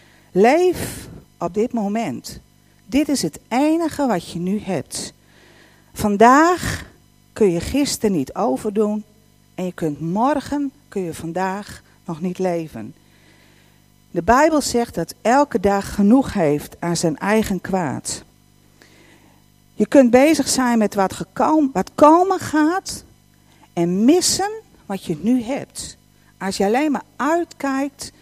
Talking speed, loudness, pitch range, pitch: 130 wpm, -19 LUFS, 180-280 Hz, 215 Hz